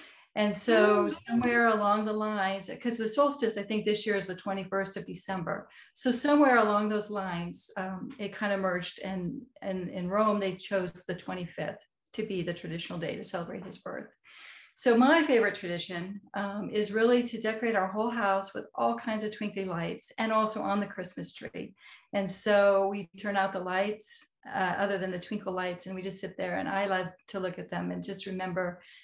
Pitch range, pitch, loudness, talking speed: 185-215 Hz, 200 Hz, -30 LUFS, 200 wpm